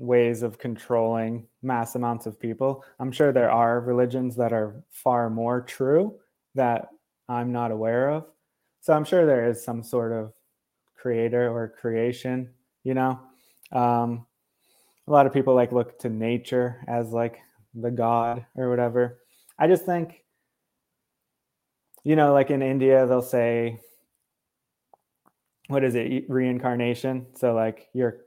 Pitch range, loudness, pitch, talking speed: 115-130 Hz, -24 LUFS, 120 Hz, 140 wpm